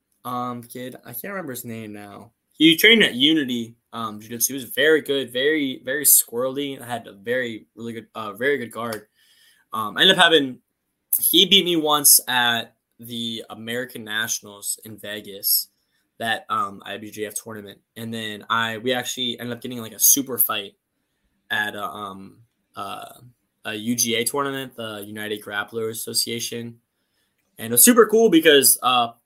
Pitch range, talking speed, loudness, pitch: 110-135 Hz, 165 wpm, -19 LUFS, 120 Hz